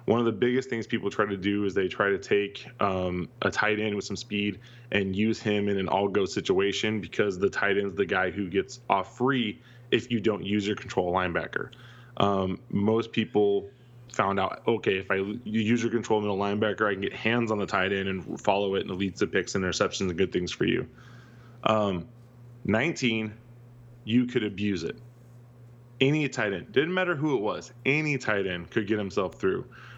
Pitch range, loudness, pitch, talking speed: 100-120 Hz, -28 LUFS, 110 Hz, 205 wpm